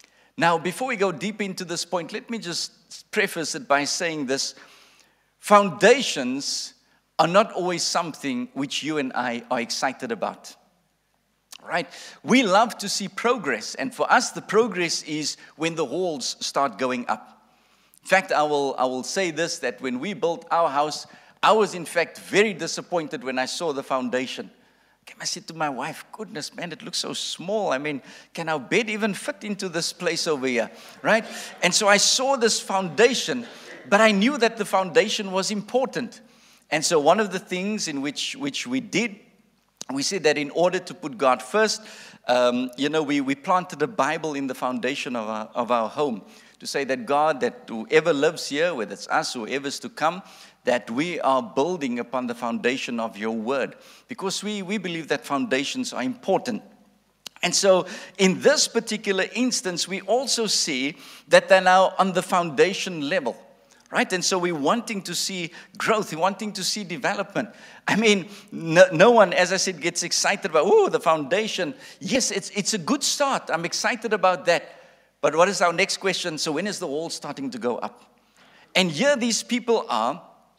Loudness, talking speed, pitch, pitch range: -23 LUFS, 185 wpm, 190 Hz, 160-220 Hz